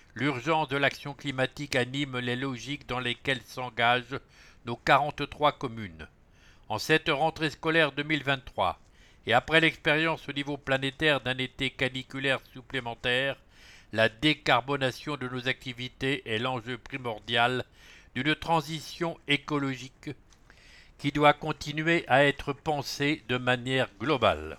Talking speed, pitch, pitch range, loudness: 115 wpm, 135 Hz, 125-145 Hz, -28 LUFS